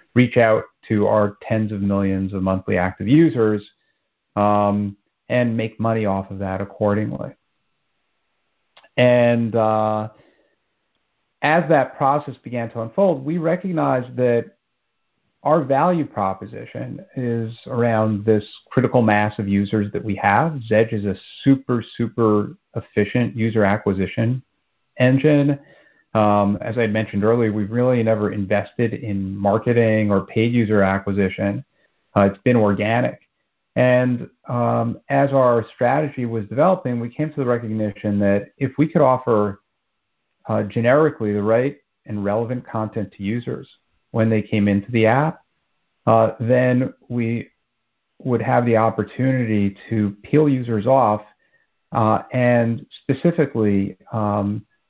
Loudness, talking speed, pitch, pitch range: -20 LUFS, 130 wpm, 110 Hz, 105-125 Hz